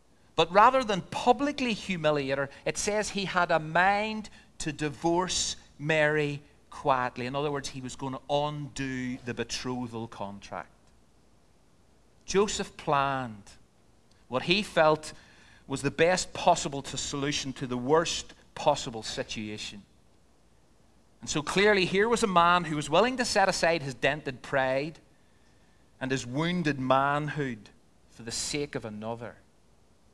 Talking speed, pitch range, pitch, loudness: 135 wpm, 120-170 Hz, 140 Hz, -28 LUFS